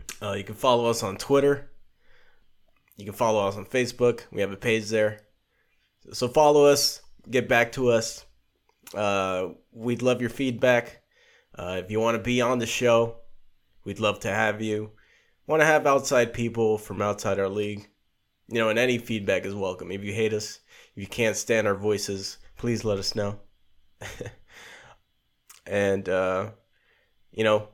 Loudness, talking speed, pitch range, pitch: -25 LUFS, 170 wpm, 100-120 Hz, 110 Hz